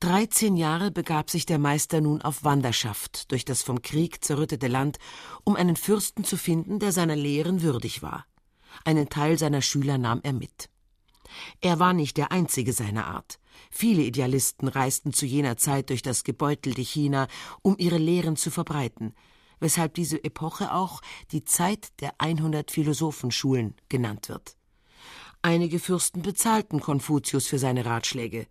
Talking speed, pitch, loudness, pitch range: 150 wpm, 150 Hz, -26 LUFS, 130-170 Hz